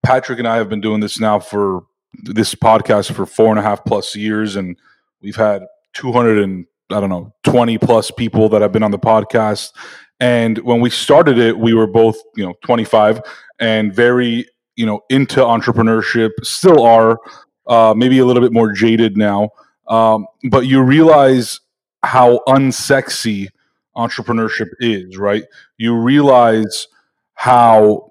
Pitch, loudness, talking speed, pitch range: 115 Hz, -13 LUFS, 160 wpm, 105-125 Hz